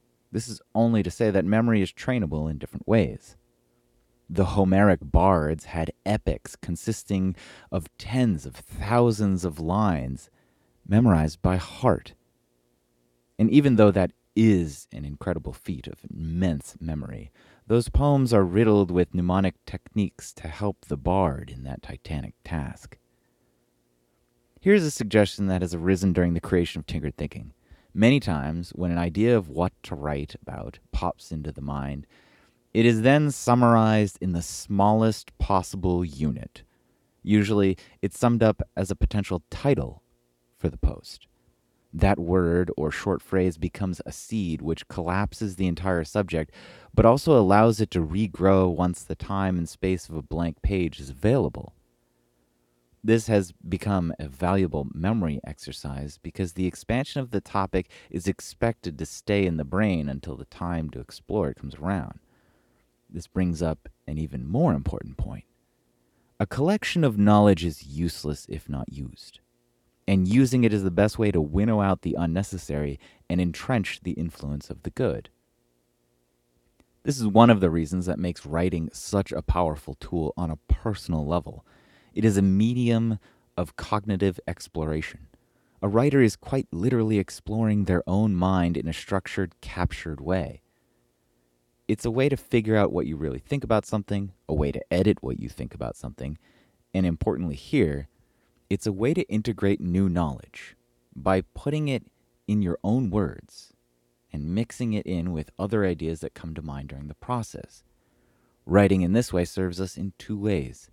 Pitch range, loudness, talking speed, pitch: 75-105 Hz, -25 LUFS, 160 wpm, 90 Hz